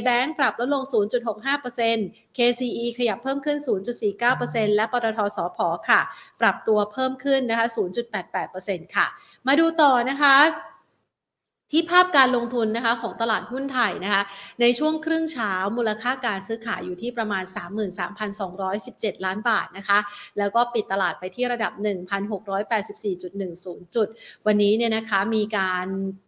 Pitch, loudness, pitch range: 225 Hz, -23 LUFS, 200-245 Hz